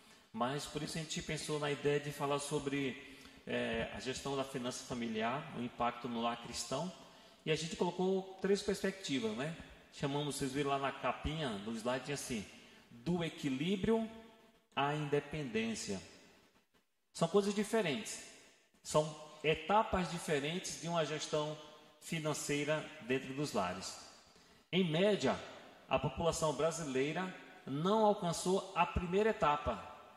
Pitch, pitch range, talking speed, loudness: 155 Hz, 140-195 Hz, 130 wpm, -37 LUFS